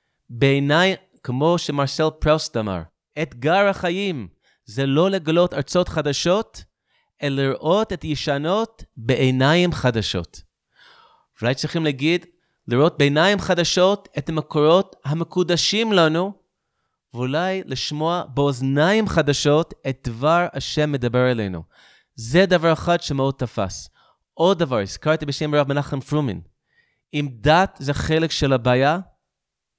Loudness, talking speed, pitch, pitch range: -20 LUFS, 110 wpm, 150 Hz, 135-175 Hz